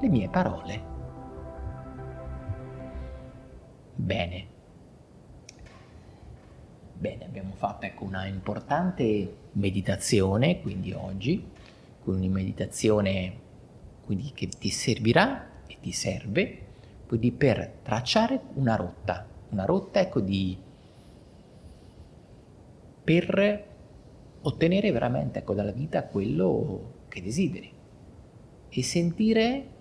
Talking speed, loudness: 85 wpm, -28 LUFS